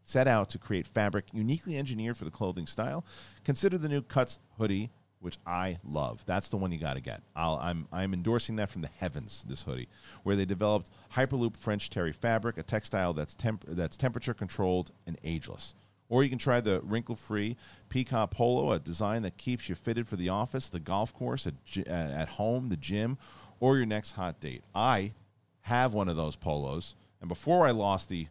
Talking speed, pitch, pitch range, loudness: 200 wpm, 105 Hz, 90-120 Hz, -32 LUFS